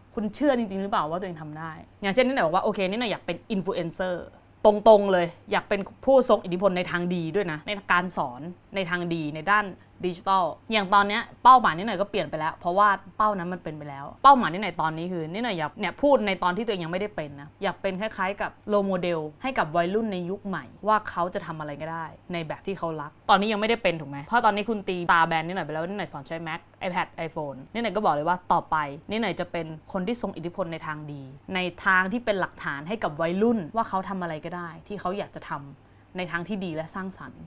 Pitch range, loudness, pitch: 165-210 Hz, -26 LUFS, 185 Hz